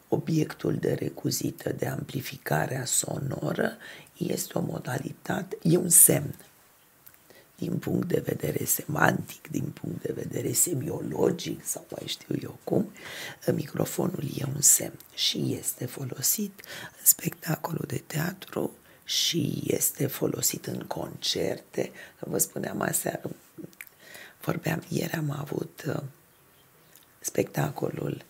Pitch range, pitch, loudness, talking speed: 150-175 Hz, 160 Hz, -27 LUFS, 110 wpm